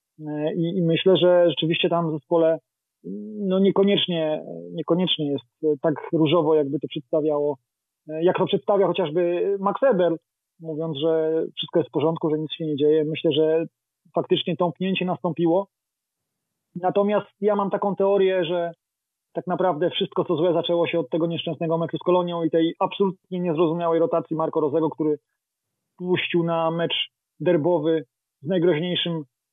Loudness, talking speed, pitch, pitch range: -23 LUFS, 145 wpm, 170 Hz, 155-180 Hz